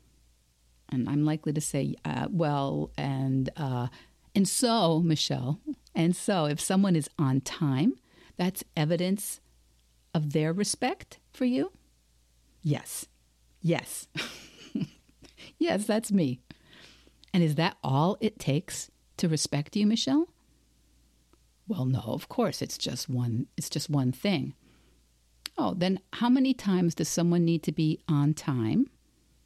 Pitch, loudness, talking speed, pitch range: 150 Hz, -29 LUFS, 130 wpm, 120-180 Hz